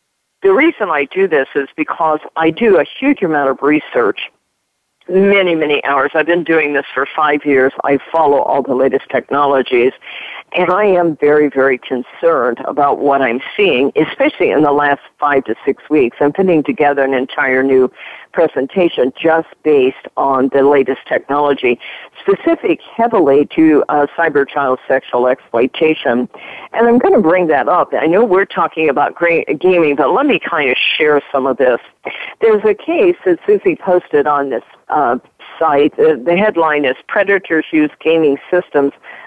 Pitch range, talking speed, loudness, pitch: 140-205 Hz, 170 wpm, -13 LUFS, 155 Hz